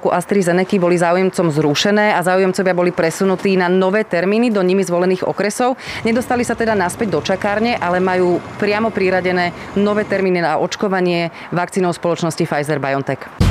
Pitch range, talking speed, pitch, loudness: 175-205 Hz, 145 wpm, 185 Hz, -16 LUFS